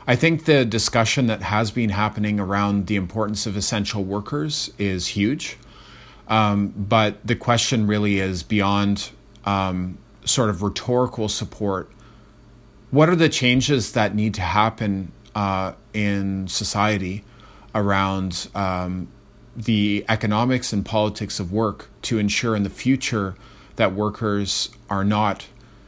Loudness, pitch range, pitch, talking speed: -22 LUFS, 100-115 Hz, 105 Hz, 130 wpm